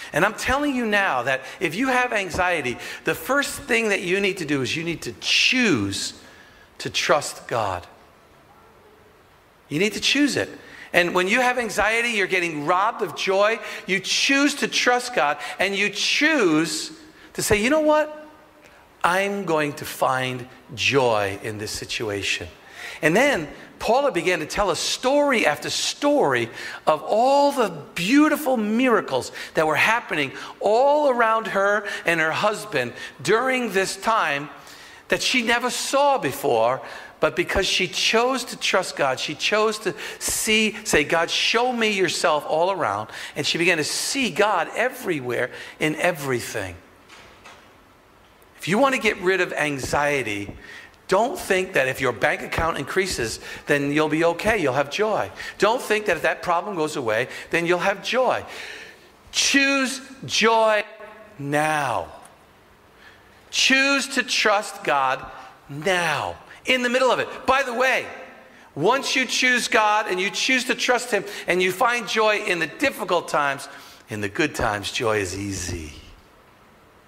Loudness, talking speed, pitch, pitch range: -21 LUFS, 155 wpm, 200 Hz, 150-245 Hz